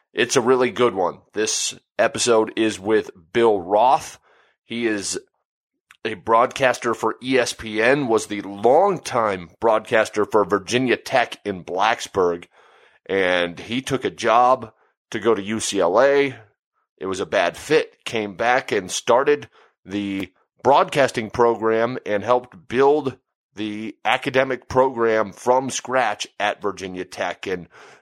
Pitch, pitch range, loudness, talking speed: 115 Hz, 105-130 Hz, -20 LUFS, 125 wpm